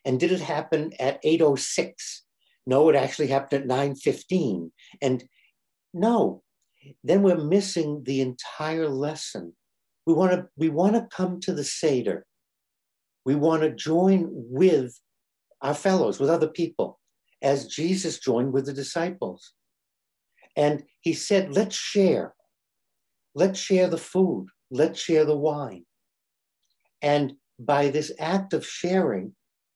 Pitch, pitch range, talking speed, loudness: 155 Hz, 140-180 Hz, 125 wpm, -25 LUFS